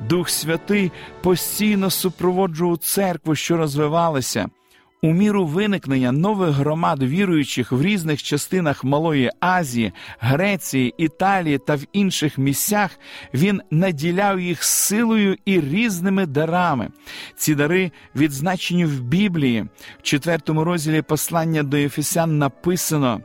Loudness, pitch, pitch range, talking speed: -20 LUFS, 165 Hz, 145-185 Hz, 110 wpm